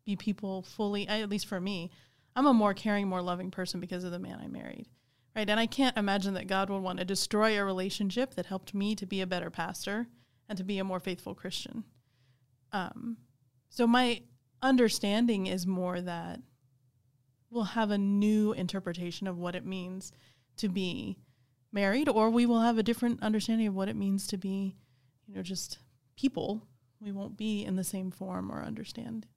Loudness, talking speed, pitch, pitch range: -32 LUFS, 190 wpm, 195 Hz, 175-215 Hz